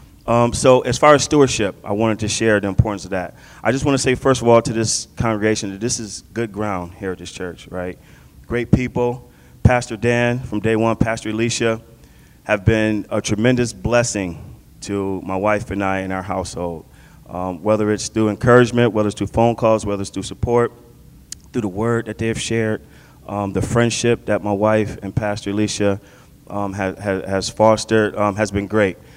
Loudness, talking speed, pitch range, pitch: -19 LUFS, 195 wpm, 100-120 Hz, 110 Hz